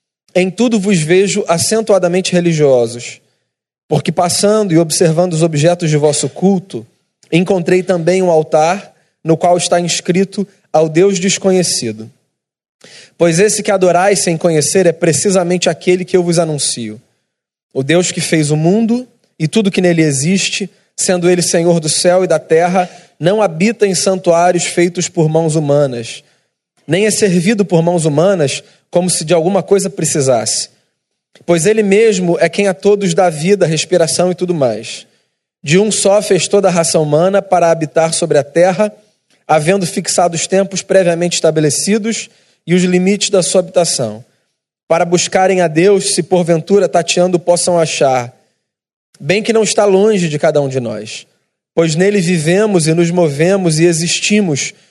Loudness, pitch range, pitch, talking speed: -12 LUFS, 165-195 Hz, 175 Hz, 155 wpm